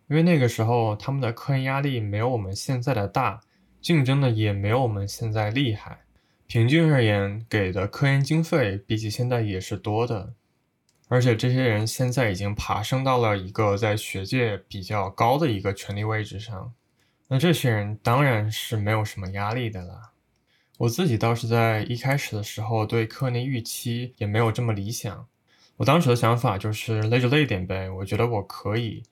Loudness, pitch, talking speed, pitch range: -24 LUFS, 115 Hz, 285 characters per minute, 105-125 Hz